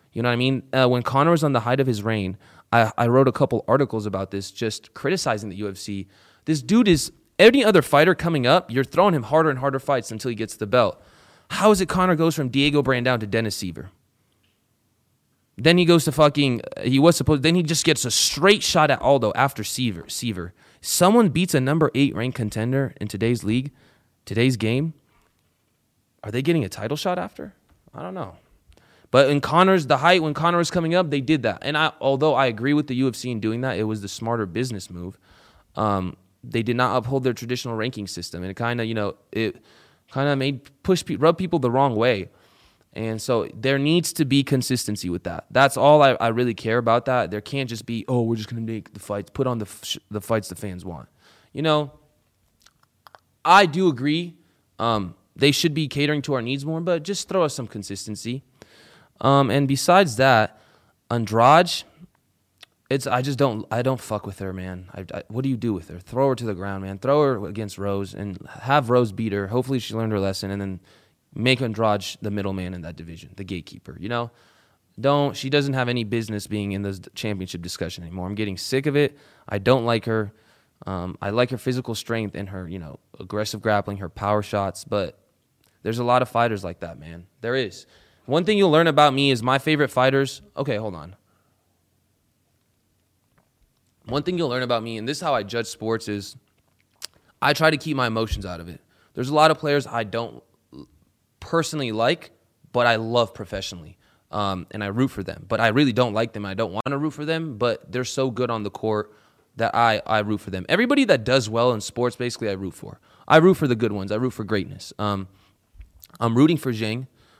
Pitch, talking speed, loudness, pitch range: 120 Hz, 215 wpm, -22 LUFS, 105-140 Hz